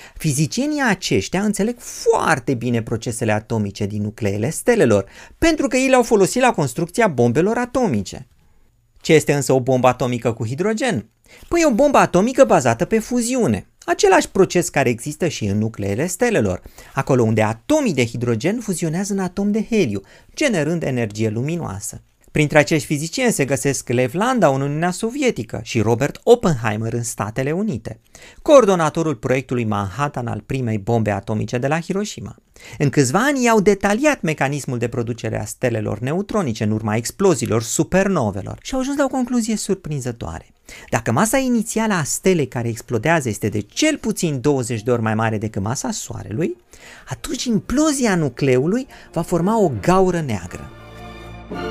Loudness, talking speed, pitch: -19 LUFS, 150 wpm, 150 Hz